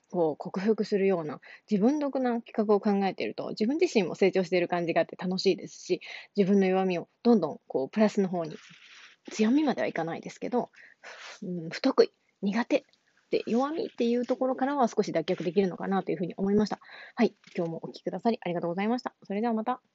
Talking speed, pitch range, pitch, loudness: 435 characters per minute, 185-240 Hz, 210 Hz, -29 LUFS